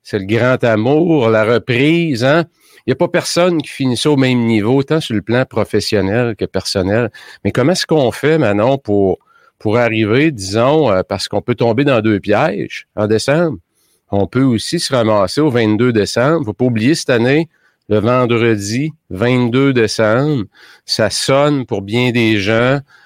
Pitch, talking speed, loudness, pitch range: 125 Hz, 170 wpm, -14 LUFS, 110-145 Hz